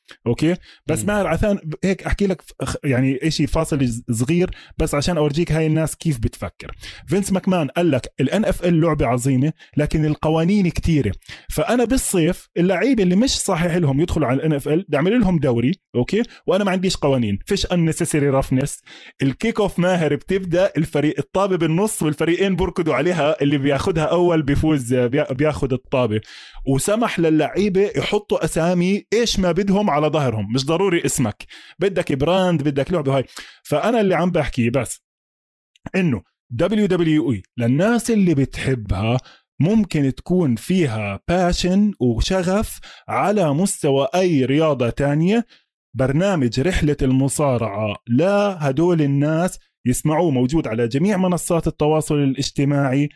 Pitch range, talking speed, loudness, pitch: 135-185 Hz, 135 wpm, -19 LUFS, 155 Hz